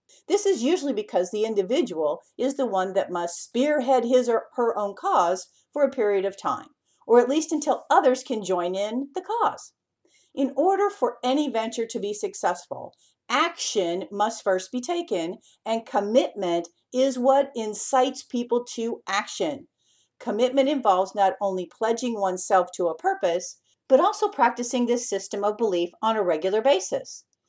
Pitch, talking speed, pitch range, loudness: 235 Hz, 160 wpm, 195-270 Hz, -24 LUFS